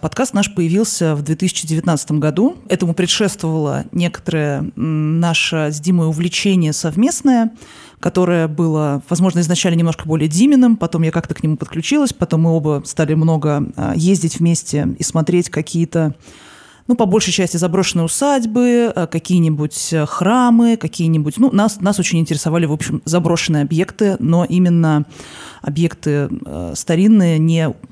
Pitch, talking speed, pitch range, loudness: 170 Hz, 130 wpm, 160-185 Hz, -16 LUFS